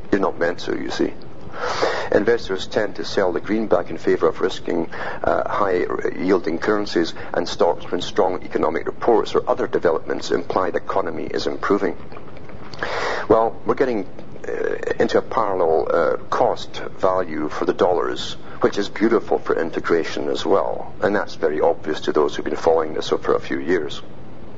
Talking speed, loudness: 165 wpm, -21 LUFS